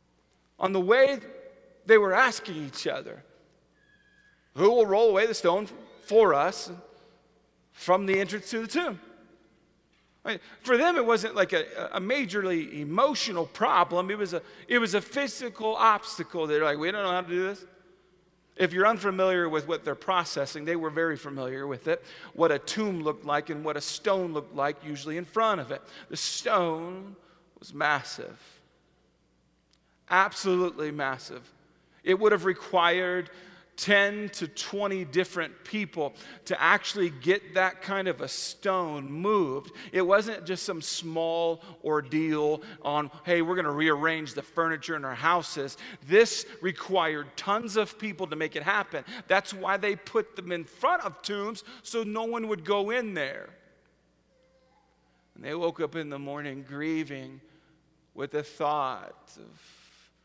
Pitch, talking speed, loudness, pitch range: 180 Hz, 155 wpm, -28 LUFS, 155-205 Hz